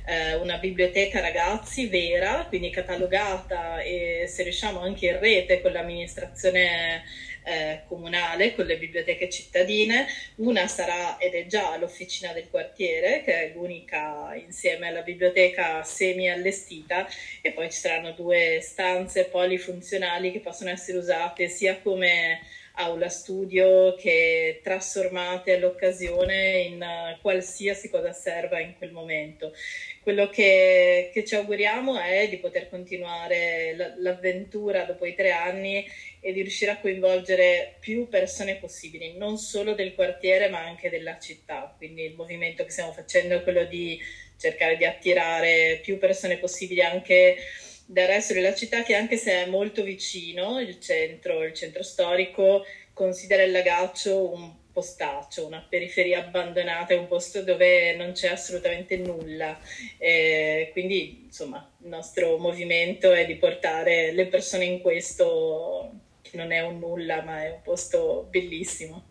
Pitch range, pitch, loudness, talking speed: 175-200 Hz, 180 Hz, -25 LUFS, 140 wpm